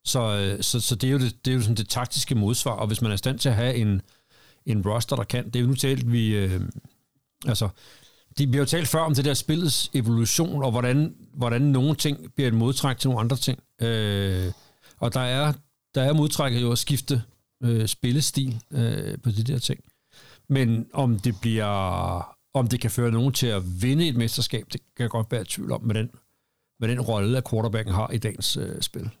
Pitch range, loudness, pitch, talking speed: 115-135 Hz, -25 LUFS, 125 Hz, 220 wpm